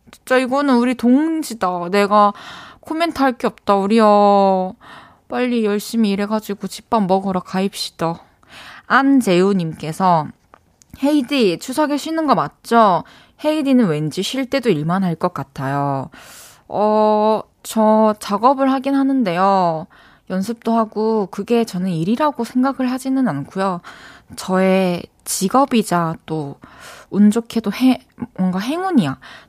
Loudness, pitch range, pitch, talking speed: -17 LUFS, 185-255 Hz, 215 Hz, 255 characters per minute